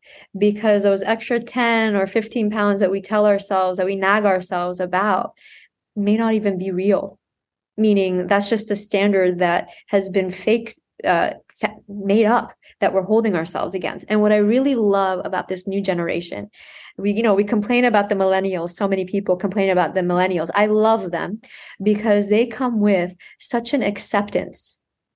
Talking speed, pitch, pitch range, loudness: 170 wpm, 205 Hz, 190-220 Hz, -19 LUFS